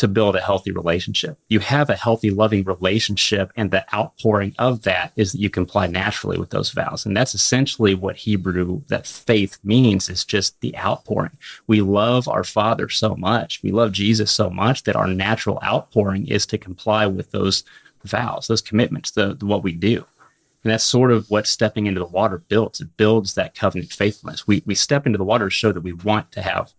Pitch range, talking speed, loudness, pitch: 95-115 Hz, 205 wpm, -20 LUFS, 105 Hz